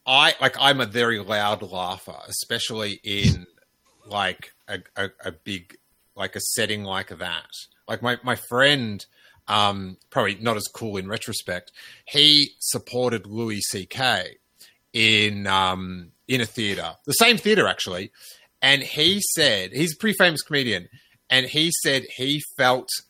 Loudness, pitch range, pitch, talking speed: -21 LUFS, 100-135 Hz, 115 Hz, 150 wpm